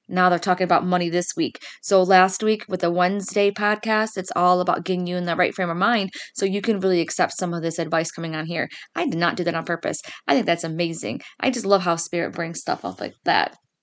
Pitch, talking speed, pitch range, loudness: 180 Hz, 250 wpm, 170-195 Hz, -22 LUFS